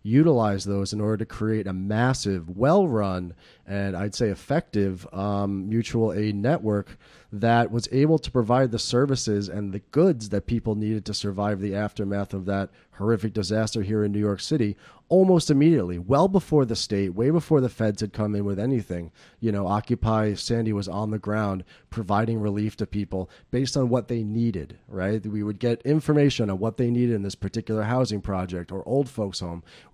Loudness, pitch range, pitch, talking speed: -25 LUFS, 100-120 Hz, 110 Hz, 190 wpm